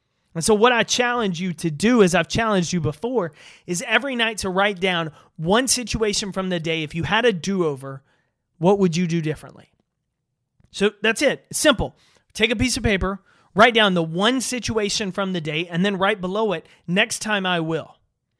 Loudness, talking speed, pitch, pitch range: -21 LUFS, 200 wpm, 190 Hz, 165-220 Hz